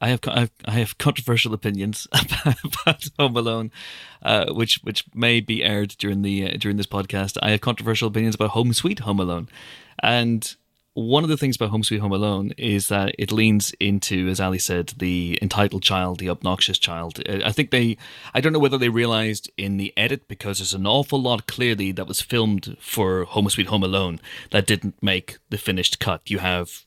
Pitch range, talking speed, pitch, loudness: 95-120 Hz, 200 wpm, 105 Hz, -22 LUFS